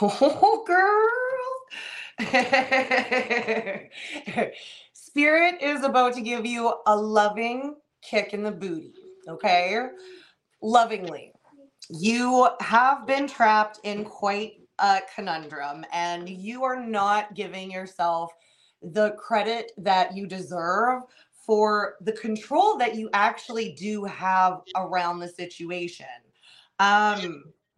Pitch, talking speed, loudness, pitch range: 215 Hz, 100 wpm, -24 LUFS, 190-255 Hz